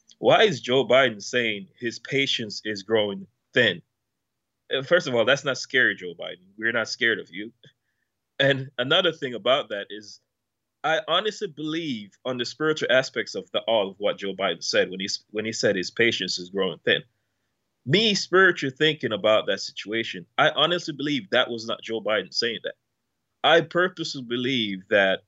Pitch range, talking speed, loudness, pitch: 110-155 Hz, 175 wpm, -24 LUFS, 125 Hz